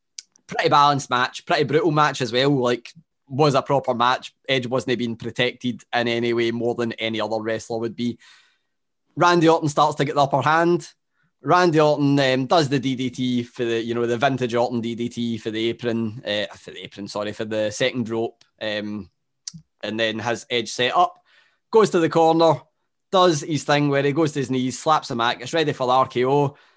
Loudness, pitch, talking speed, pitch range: -21 LUFS, 130 Hz, 200 wpm, 120-150 Hz